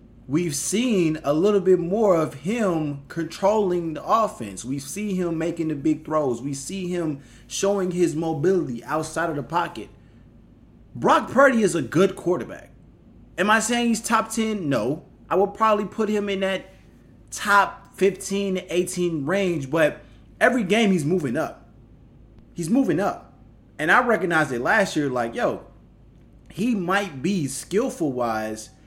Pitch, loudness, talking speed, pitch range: 175 Hz, -23 LUFS, 155 wpm, 145-200 Hz